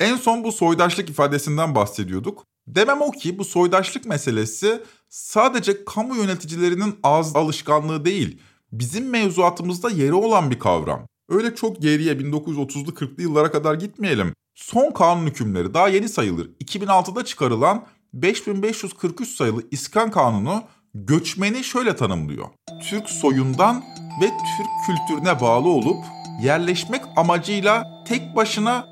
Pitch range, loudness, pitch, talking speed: 150-215 Hz, -21 LUFS, 175 Hz, 120 wpm